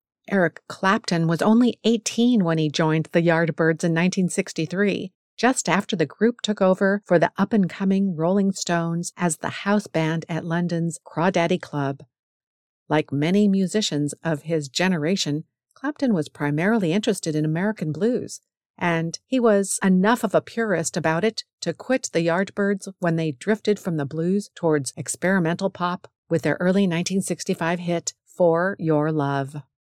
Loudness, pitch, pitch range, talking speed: -22 LUFS, 175 Hz, 160-200 Hz, 155 wpm